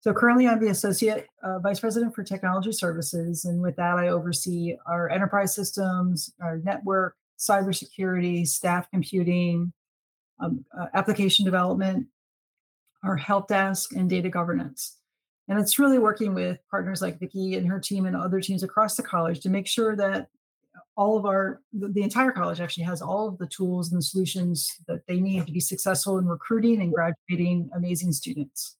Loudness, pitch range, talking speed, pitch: -26 LUFS, 175-200 Hz, 175 wpm, 190 Hz